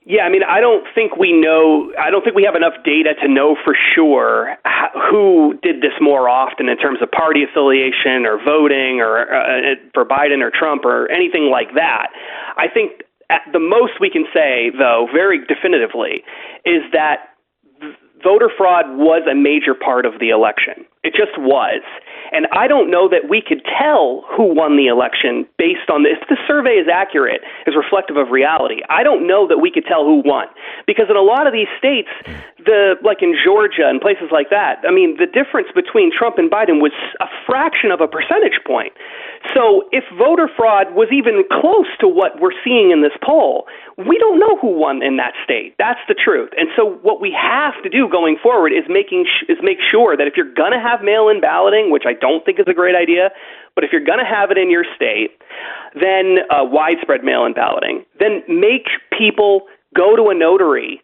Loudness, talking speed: -13 LUFS, 200 wpm